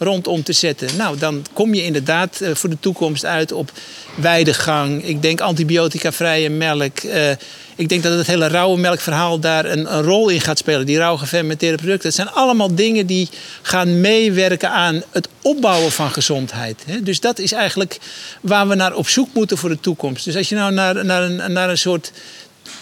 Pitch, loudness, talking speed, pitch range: 170 Hz, -16 LUFS, 190 wpm, 155-190 Hz